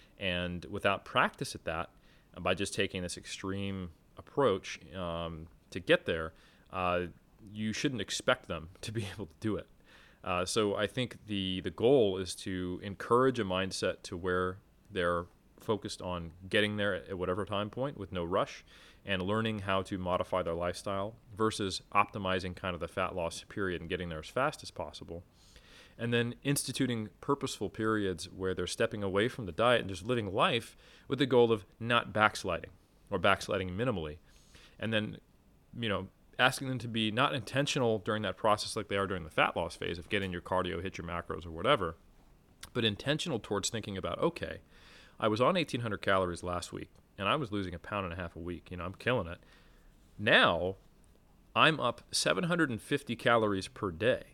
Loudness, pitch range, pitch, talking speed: -33 LUFS, 90-110 Hz, 95 Hz, 180 wpm